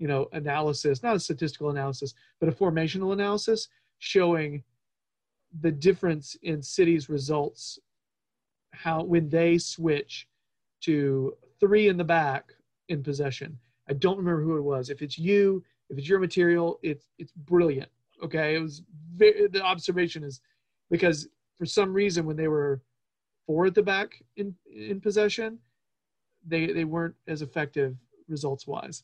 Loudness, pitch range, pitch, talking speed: -27 LUFS, 145-185 Hz, 165 Hz, 150 wpm